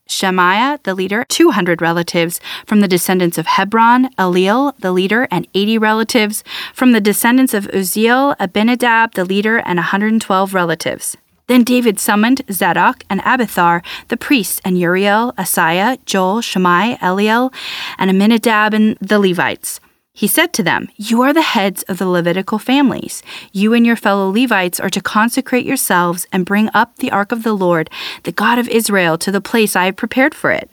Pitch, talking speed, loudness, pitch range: 210 Hz, 170 wpm, -14 LUFS, 185-235 Hz